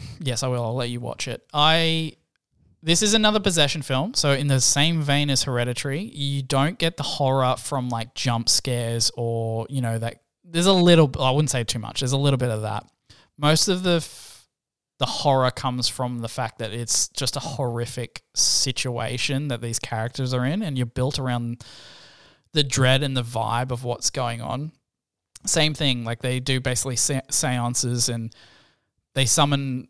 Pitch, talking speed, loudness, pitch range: 130 Hz, 185 wpm, -22 LUFS, 120-145 Hz